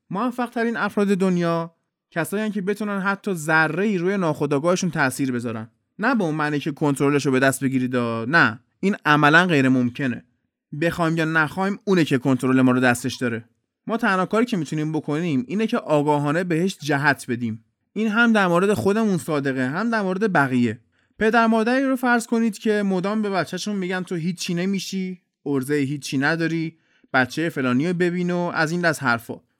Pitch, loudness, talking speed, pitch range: 165 Hz, -21 LUFS, 170 wpm, 135-195 Hz